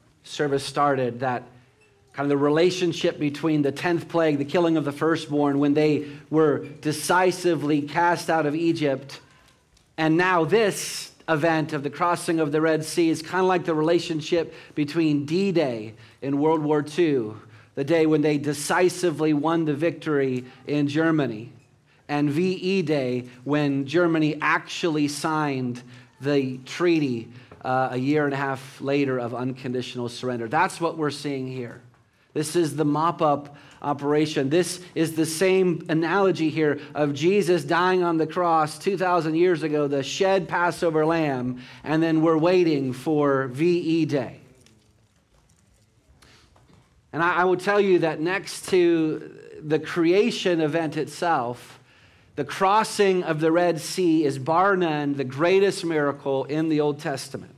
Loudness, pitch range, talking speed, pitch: -23 LUFS, 140-170 Hz, 150 wpm, 155 Hz